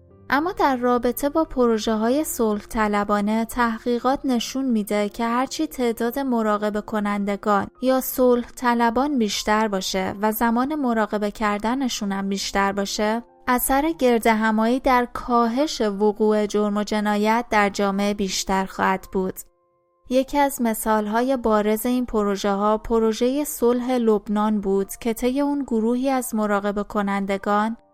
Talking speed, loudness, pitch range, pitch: 125 wpm, -22 LUFS, 210-250 Hz, 225 Hz